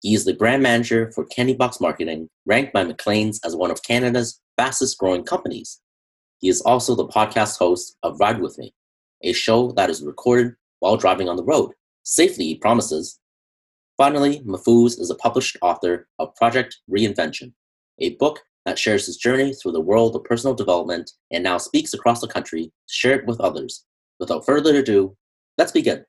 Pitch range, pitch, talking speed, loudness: 95-125 Hz, 115 Hz, 180 wpm, -20 LUFS